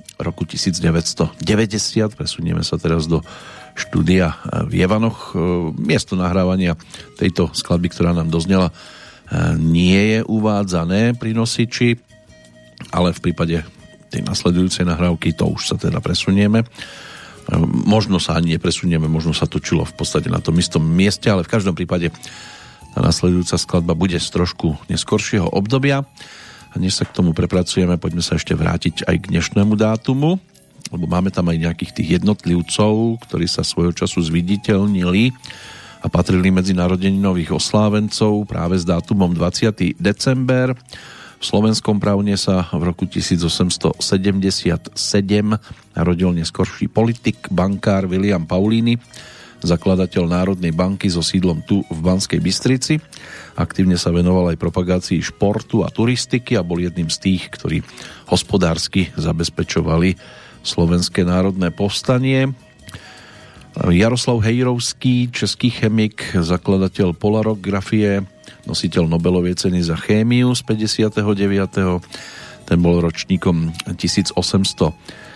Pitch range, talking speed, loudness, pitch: 85-105 Hz, 120 wpm, -18 LUFS, 95 Hz